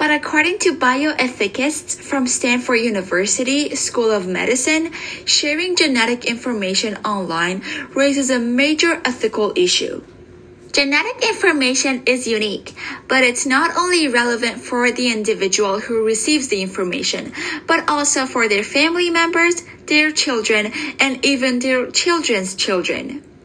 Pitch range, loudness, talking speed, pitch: 225-305 Hz, -17 LUFS, 125 wpm, 260 Hz